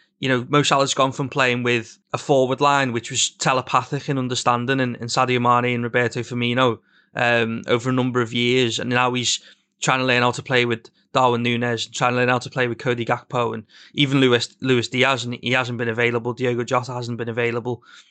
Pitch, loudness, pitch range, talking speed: 125 Hz, -20 LUFS, 120-130 Hz, 220 wpm